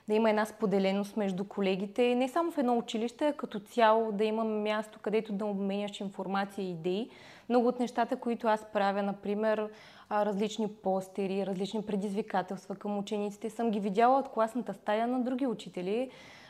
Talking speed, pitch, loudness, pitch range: 165 wpm, 215 Hz, -32 LUFS, 200-230 Hz